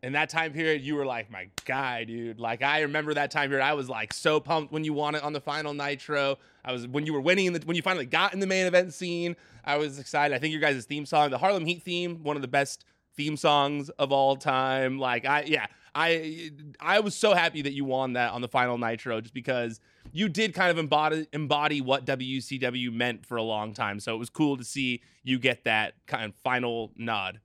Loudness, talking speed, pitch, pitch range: -28 LUFS, 245 wpm, 145 Hz, 125-155 Hz